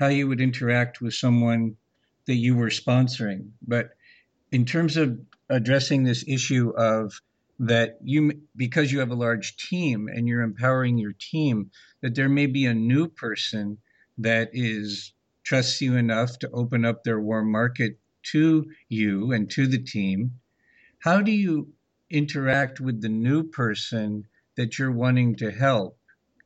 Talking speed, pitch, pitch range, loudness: 155 wpm, 120 Hz, 115-135 Hz, -24 LUFS